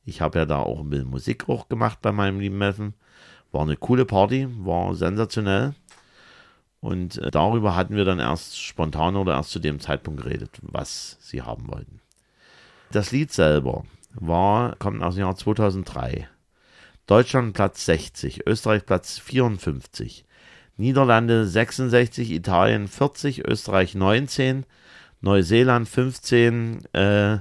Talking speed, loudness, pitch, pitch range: 135 wpm, -22 LUFS, 100 Hz, 90-115 Hz